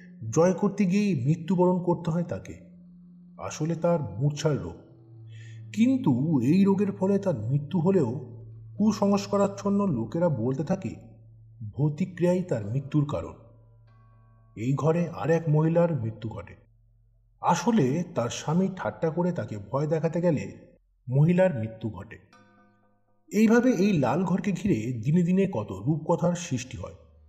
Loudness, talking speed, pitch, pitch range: -26 LUFS, 120 wpm, 150 Hz, 110-180 Hz